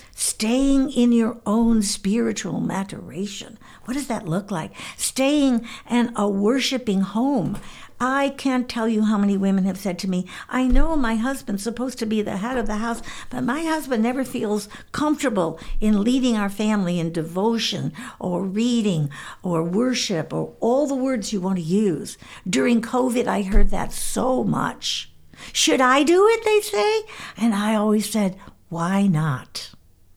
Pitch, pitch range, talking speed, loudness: 225 Hz, 195-255 Hz, 165 wpm, -22 LUFS